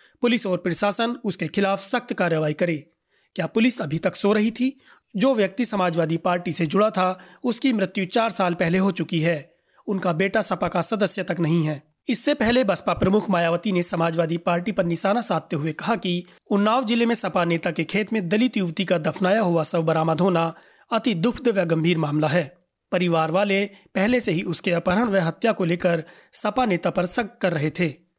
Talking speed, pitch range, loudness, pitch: 195 wpm, 170-215 Hz, -22 LUFS, 185 Hz